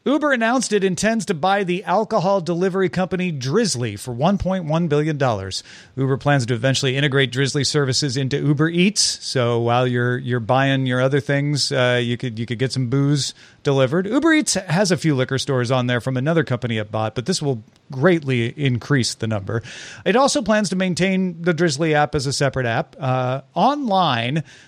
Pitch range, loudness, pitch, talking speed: 125-185 Hz, -20 LUFS, 140 Hz, 185 wpm